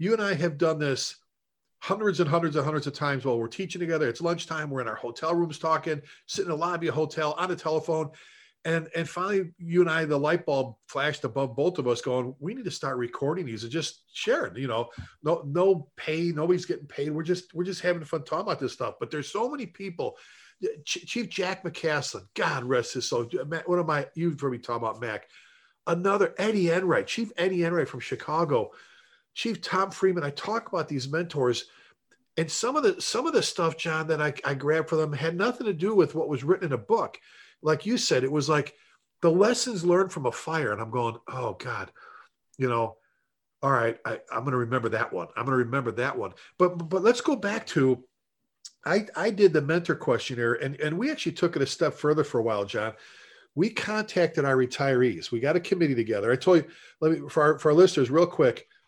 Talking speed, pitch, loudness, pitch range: 225 wpm, 160 Hz, -27 LUFS, 140-180 Hz